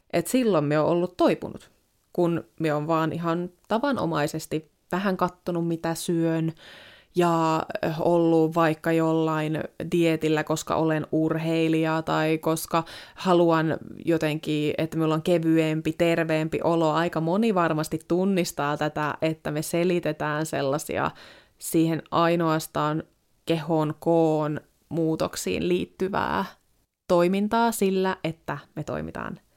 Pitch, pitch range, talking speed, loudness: 160 Hz, 155-170 Hz, 110 wpm, -25 LUFS